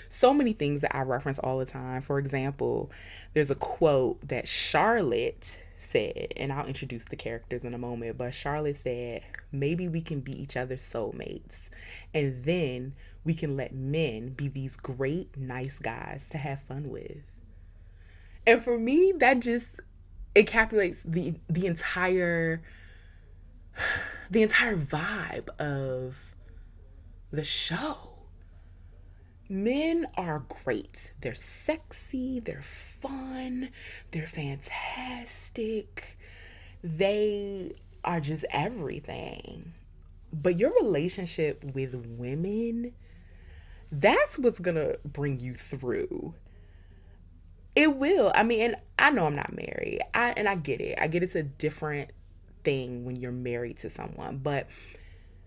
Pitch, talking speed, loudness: 140 Hz, 125 wpm, -29 LUFS